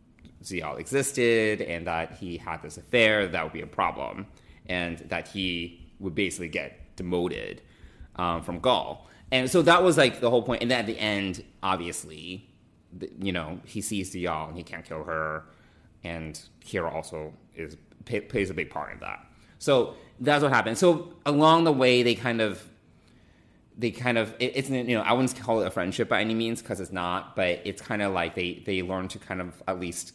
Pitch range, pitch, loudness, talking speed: 85-120 Hz, 95 Hz, -27 LUFS, 205 wpm